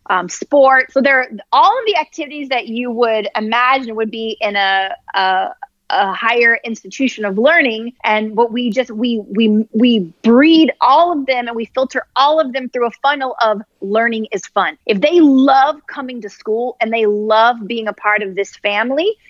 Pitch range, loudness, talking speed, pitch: 220-270 Hz, -14 LUFS, 195 wpm, 235 Hz